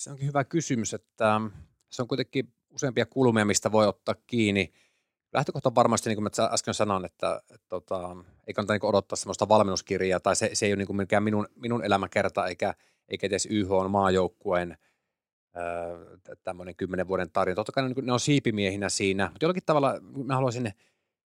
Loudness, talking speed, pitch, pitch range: -27 LUFS, 185 wpm, 105 Hz, 95-120 Hz